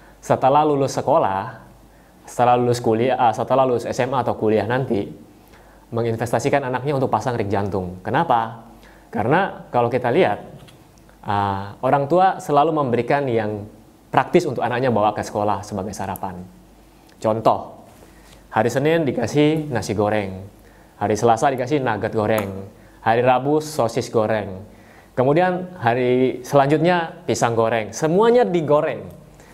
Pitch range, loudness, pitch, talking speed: 105-140 Hz, -20 LUFS, 115 Hz, 120 wpm